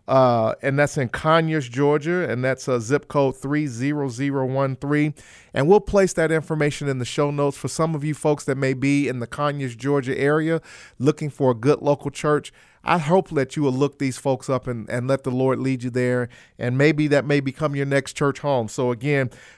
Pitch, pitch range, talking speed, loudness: 140 Hz, 130-150 Hz, 210 wpm, -22 LUFS